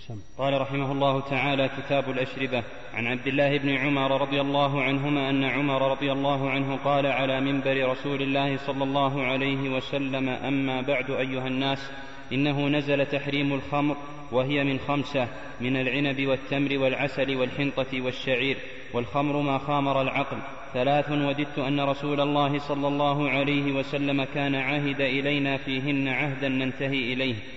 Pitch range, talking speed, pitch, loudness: 130-140 Hz, 140 wpm, 135 Hz, -26 LUFS